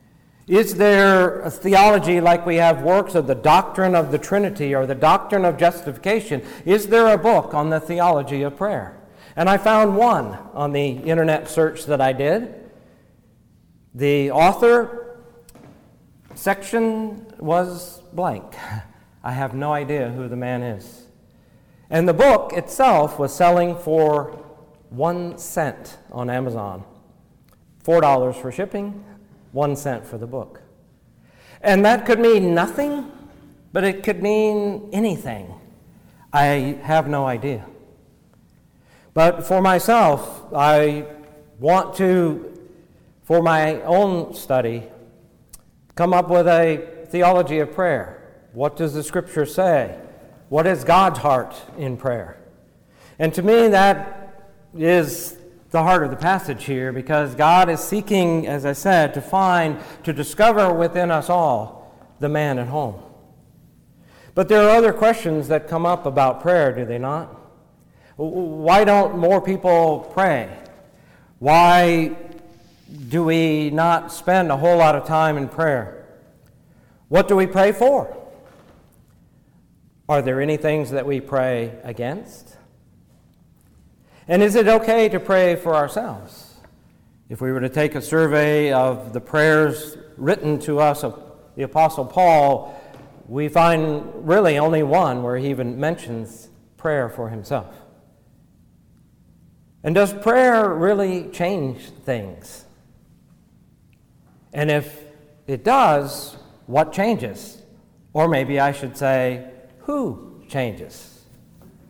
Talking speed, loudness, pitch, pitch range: 130 wpm, -18 LUFS, 160 Hz, 140-185 Hz